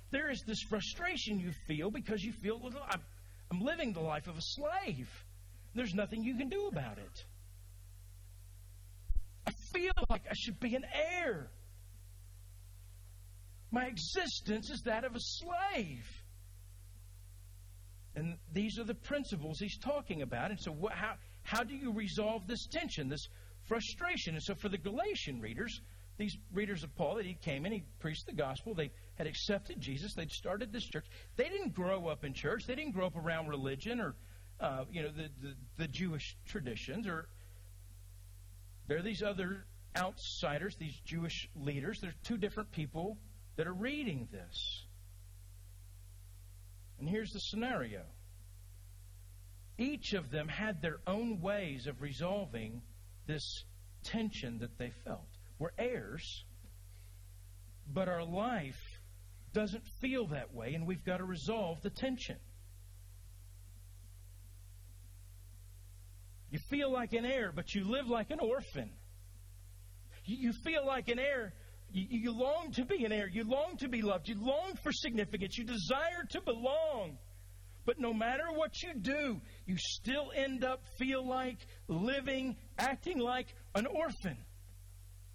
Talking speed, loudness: 145 wpm, -39 LUFS